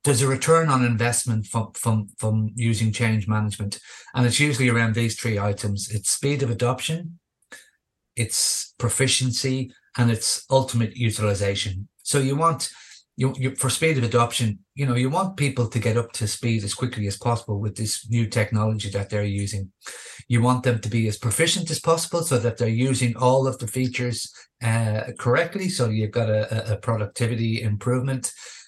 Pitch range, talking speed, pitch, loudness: 110-130 Hz, 175 wpm, 120 Hz, -23 LUFS